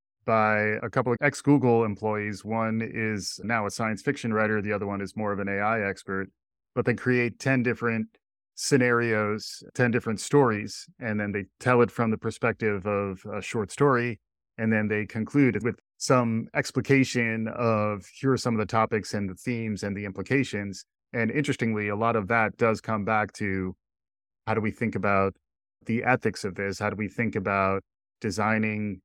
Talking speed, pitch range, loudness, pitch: 185 wpm, 100-120 Hz, -26 LUFS, 110 Hz